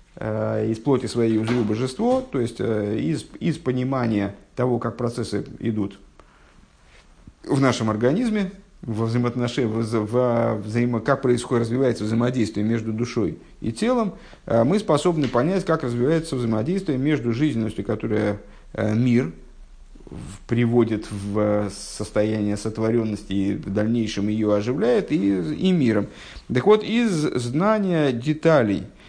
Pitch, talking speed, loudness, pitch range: 115 Hz, 115 wpm, -23 LUFS, 105-135 Hz